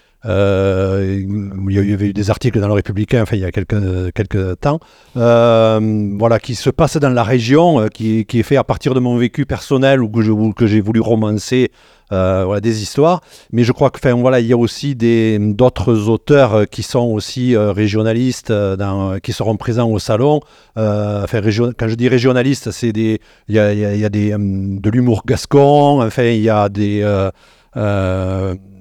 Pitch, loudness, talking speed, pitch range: 110 Hz, -15 LUFS, 200 wpm, 105-125 Hz